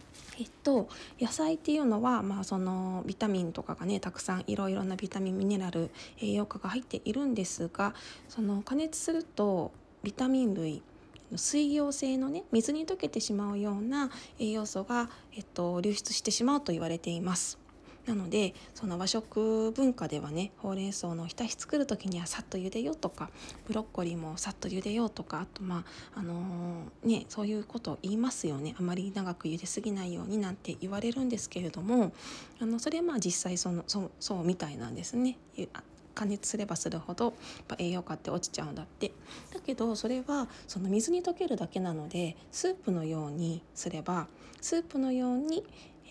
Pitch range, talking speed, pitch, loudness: 180-245 Hz, 375 characters per minute, 205 Hz, -34 LUFS